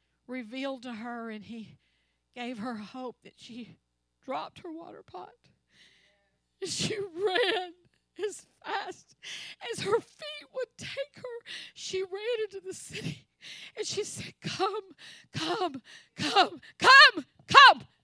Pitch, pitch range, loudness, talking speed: 315 Hz, 240-400 Hz, -25 LUFS, 125 wpm